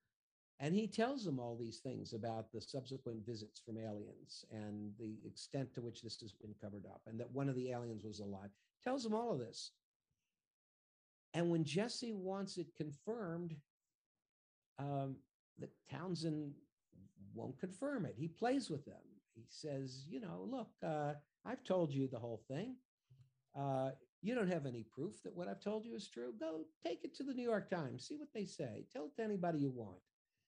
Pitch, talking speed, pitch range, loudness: 140 Hz, 185 wpm, 115-190 Hz, -45 LUFS